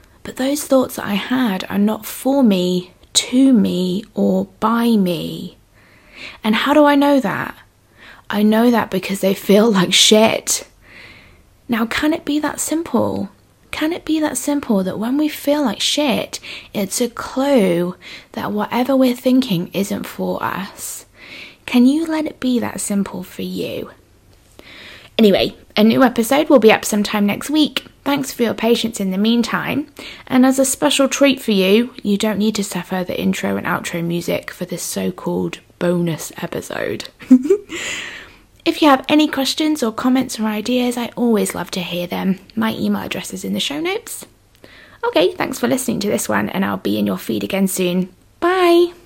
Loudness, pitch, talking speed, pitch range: -17 LUFS, 230 Hz, 175 wpm, 195-275 Hz